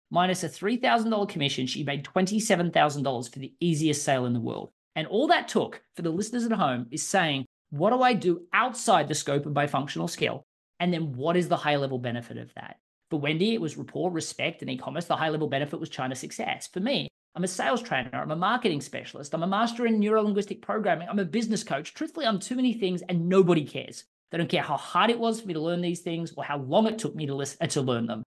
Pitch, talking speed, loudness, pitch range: 170 Hz, 245 wpm, -27 LUFS, 145-200 Hz